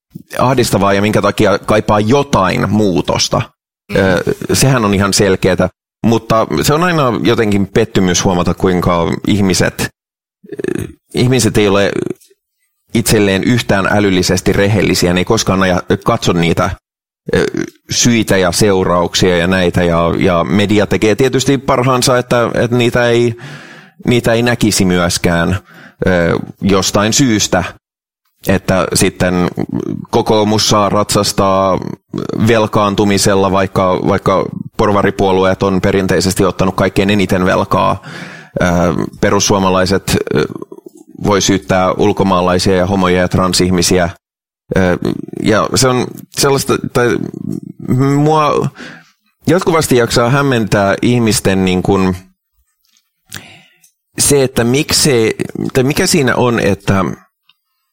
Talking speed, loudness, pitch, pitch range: 100 wpm, -12 LUFS, 100 Hz, 95-120 Hz